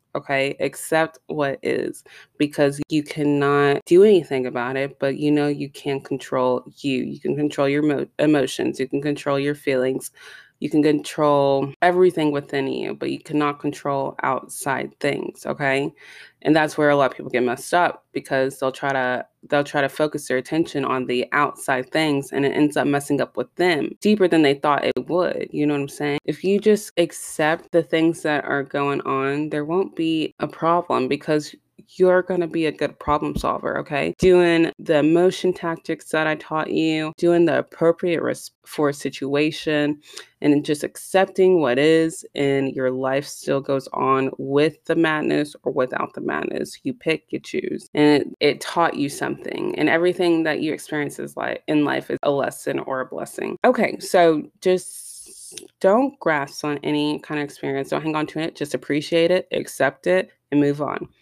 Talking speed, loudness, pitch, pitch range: 185 wpm, -21 LUFS, 150 Hz, 140-165 Hz